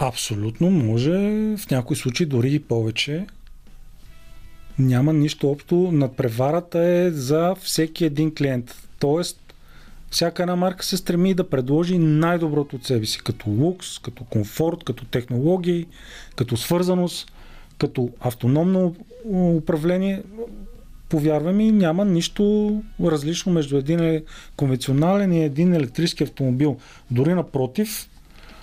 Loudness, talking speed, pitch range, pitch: -21 LUFS, 115 wpm, 135-180 Hz, 160 Hz